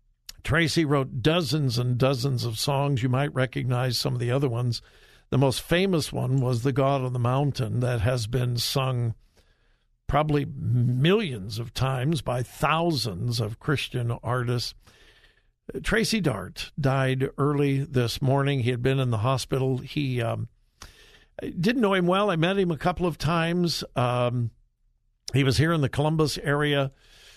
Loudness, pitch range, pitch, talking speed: -25 LUFS, 125-150 Hz, 135 Hz, 155 wpm